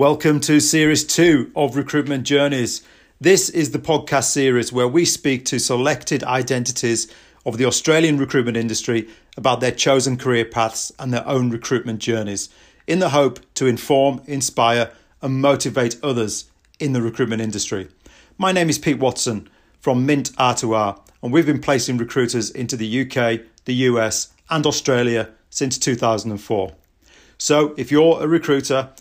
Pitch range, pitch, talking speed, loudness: 115-145 Hz, 130 Hz, 150 wpm, -19 LUFS